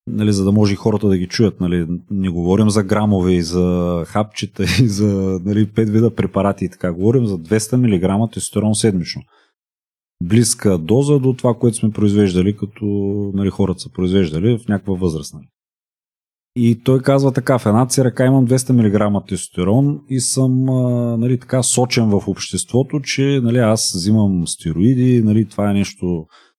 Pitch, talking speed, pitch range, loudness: 105 Hz, 165 wpm, 95-125 Hz, -16 LUFS